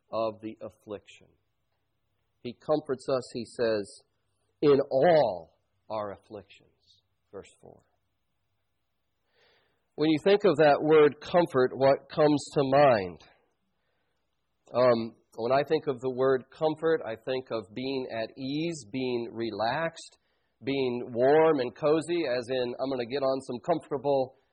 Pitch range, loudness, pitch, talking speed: 115-150 Hz, -27 LUFS, 130 Hz, 130 wpm